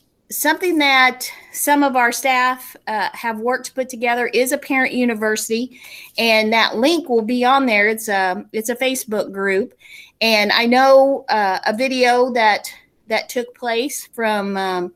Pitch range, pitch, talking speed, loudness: 220-260 Hz, 245 Hz, 165 wpm, -17 LUFS